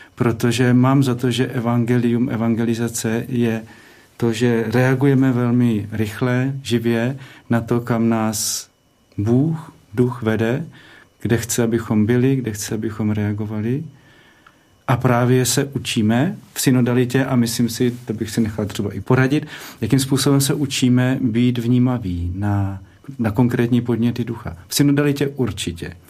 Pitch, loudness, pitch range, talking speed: 120 Hz, -19 LUFS, 115-130 Hz, 135 wpm